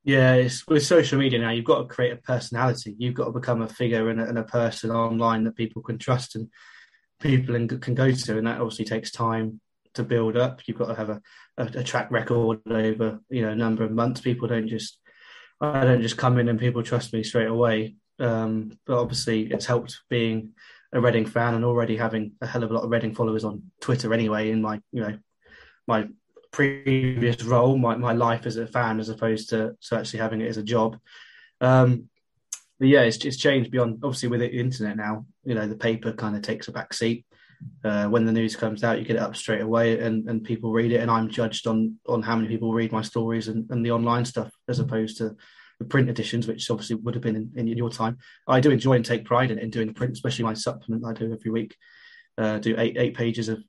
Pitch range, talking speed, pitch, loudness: 110-125 Hz, 235 wpm, 115 Hz, -25 LUFS